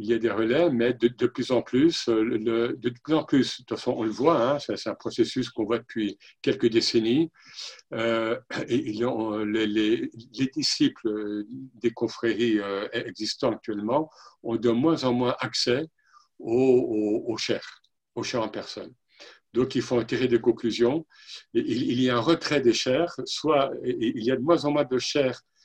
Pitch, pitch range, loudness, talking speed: 125 Hz, 115-170 Hz, -26 LUFS, 190 wpm